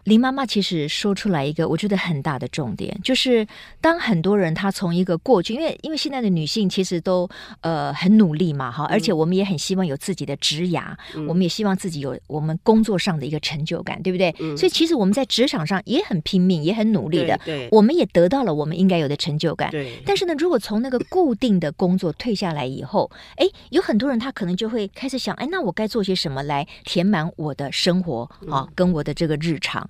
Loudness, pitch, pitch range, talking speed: -21 LUFS, 185 Hz, 160-215 Hz, 350 characters per minute